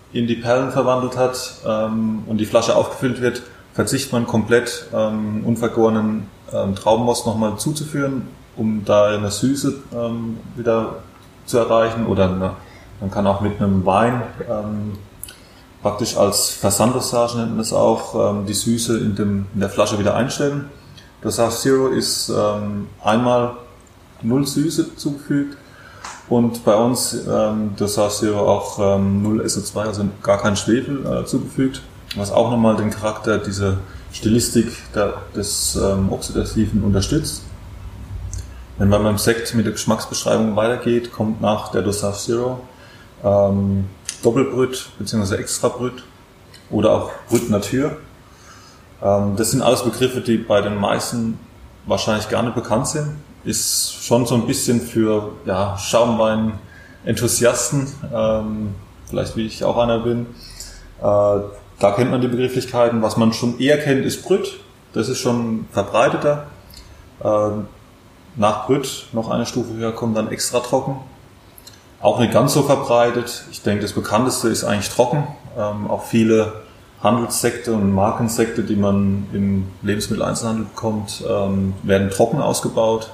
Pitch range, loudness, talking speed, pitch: 100-120 Hz, -19 LUFS, 140 wpm, 110 Hz